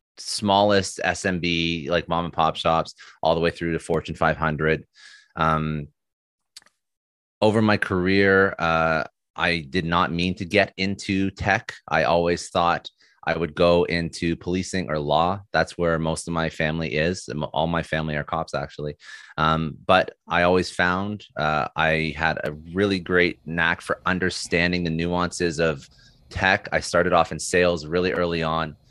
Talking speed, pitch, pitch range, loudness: 160 wpm, 85 Hz, 80-90 Hz, -23 LUFS